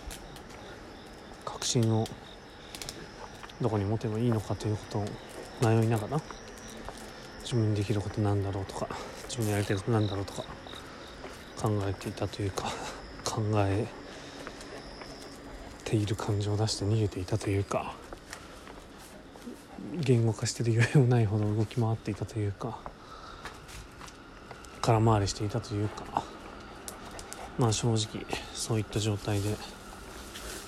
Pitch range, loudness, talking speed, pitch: 105-115 Hz, -31 LUFS, 255 characters per minute, 110 Hz